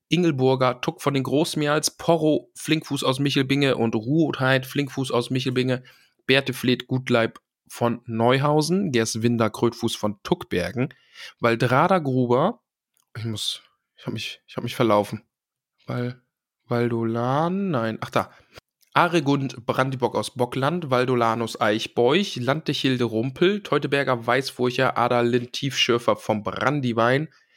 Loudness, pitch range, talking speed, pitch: -23 LUFS, 120-140 Hz, 115 wpm, 130 Hz